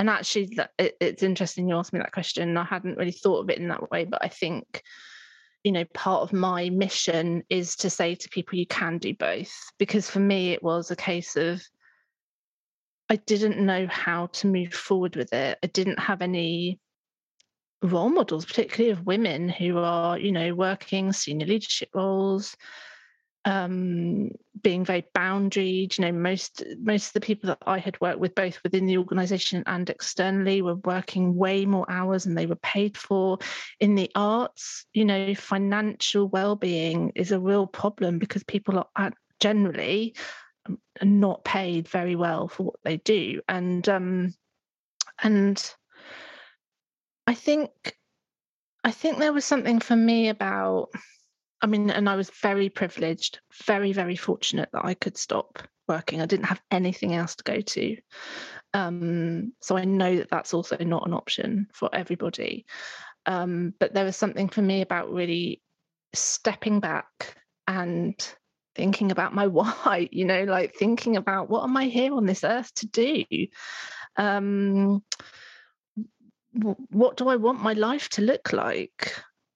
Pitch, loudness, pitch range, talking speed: 195 Hz, -26 LUFS, 180-210 Hz, 160 wpm